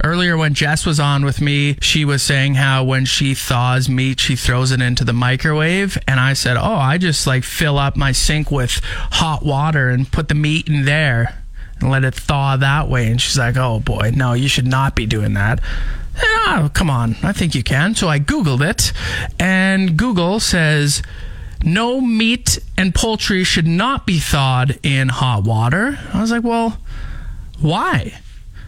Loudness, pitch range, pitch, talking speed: -16 LUFS, 130-165 Hz, 140 Hz, 190 wpm